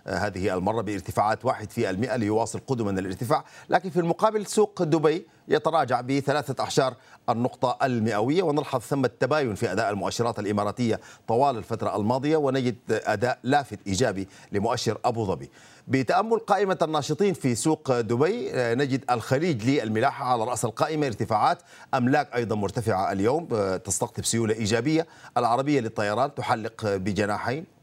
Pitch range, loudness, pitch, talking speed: 110-140 Hz, -26 LUFS, 125 Hz, 130 wpm